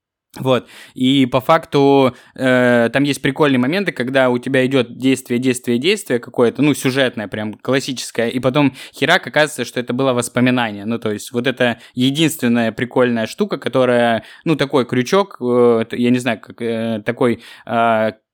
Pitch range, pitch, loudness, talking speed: 120-135 Hz, 125 Hz, -17 LUFS, 160 wpm